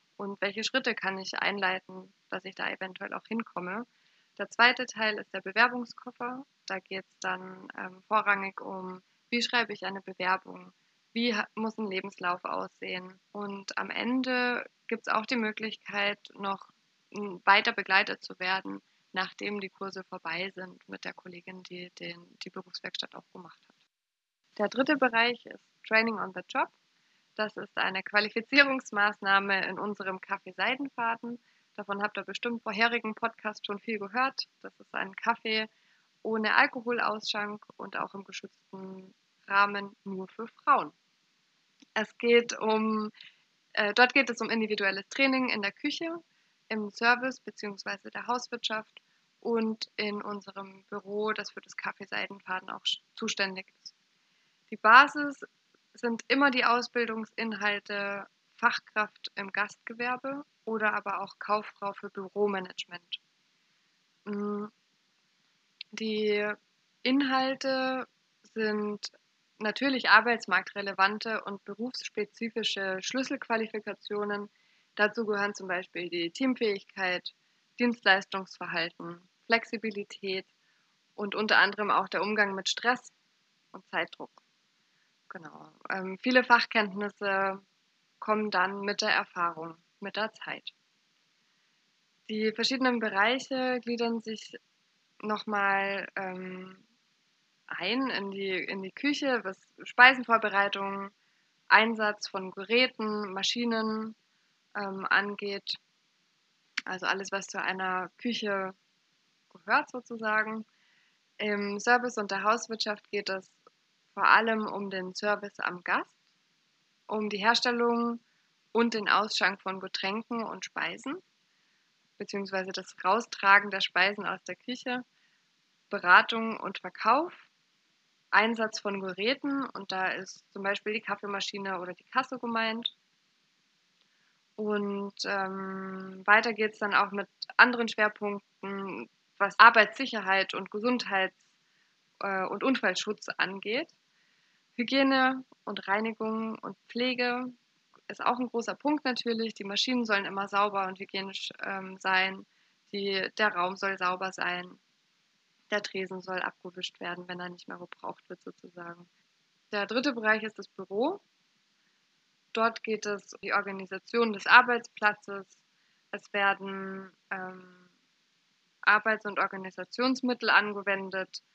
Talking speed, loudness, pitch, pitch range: 120 wpm, -29 LUFS, 205 Hz, 195-230 Hz